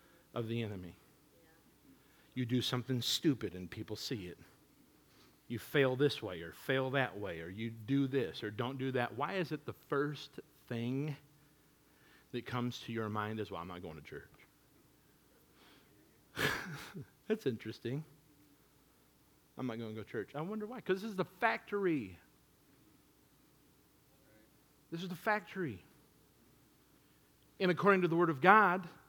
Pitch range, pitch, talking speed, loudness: 115-155 Hz, 135 Hz, 150 wpm, -36 LUFS